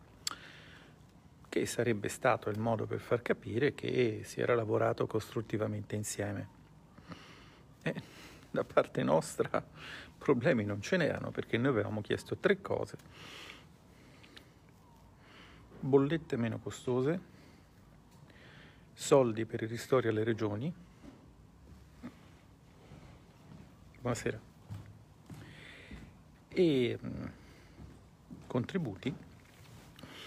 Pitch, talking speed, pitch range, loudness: 115 Hz, 85 wpm, 105-125 Hz, -34 LUFS